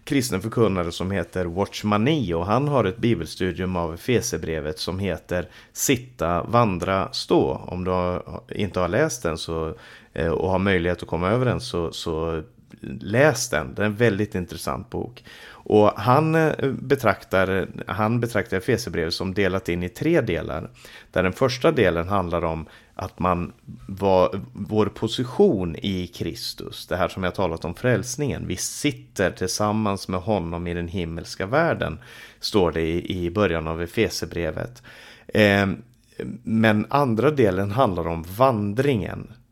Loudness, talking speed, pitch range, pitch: -23 LUFS, 145 wpm, 90-115 Hz, 100 Hz